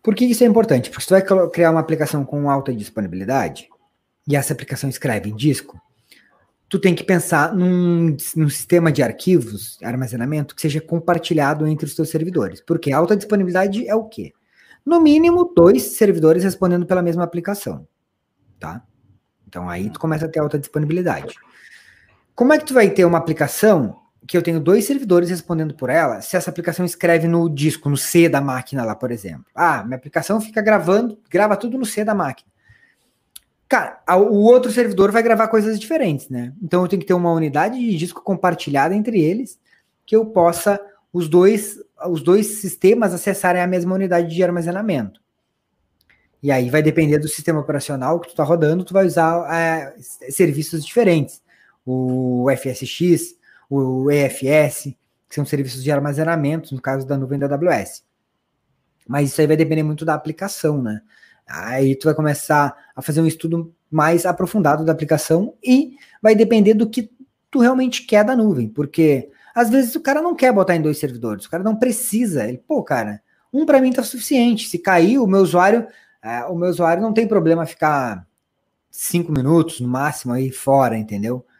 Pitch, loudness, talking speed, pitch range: 170 Hz, -18 LUFS, 180 wpm, 145-200 Hz